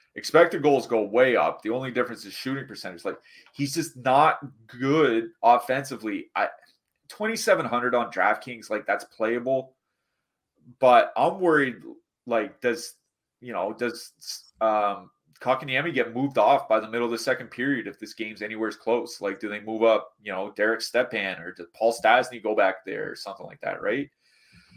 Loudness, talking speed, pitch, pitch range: -25 LUFS, 170 wpm, 125 Hz, 110-165 Hz